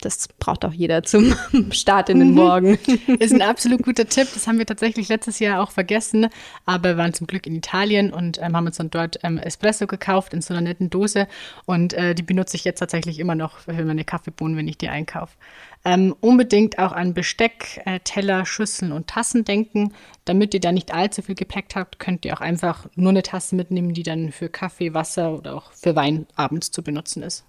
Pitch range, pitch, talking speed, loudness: 170-205 Hz, 185 Hz, 215 wpm, -20 LUFS